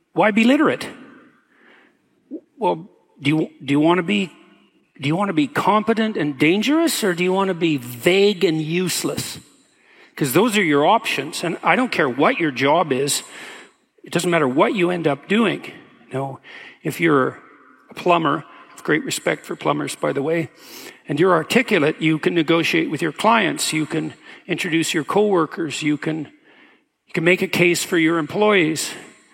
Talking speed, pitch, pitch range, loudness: 180 wpm, 170 Hz, 155-205 Hz, -19 LUFS